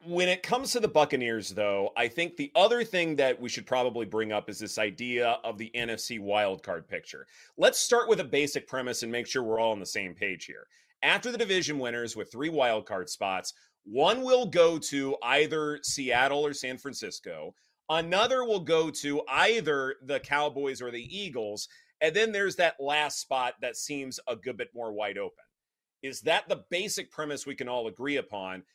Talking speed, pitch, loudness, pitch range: 195 wpm, 145 Hz, -29 LUFS, 120-185 Hz